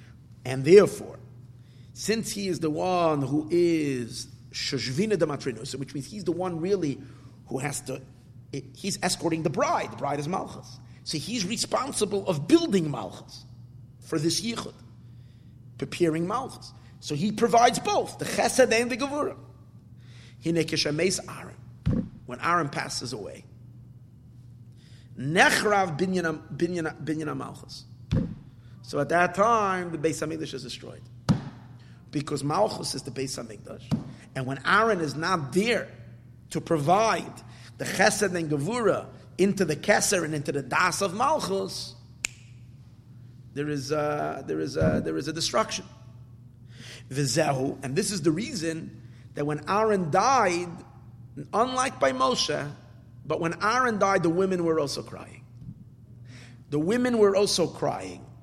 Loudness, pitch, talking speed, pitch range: -26 LUFS, 145 Hz, 130 wpm, 120-175 Hz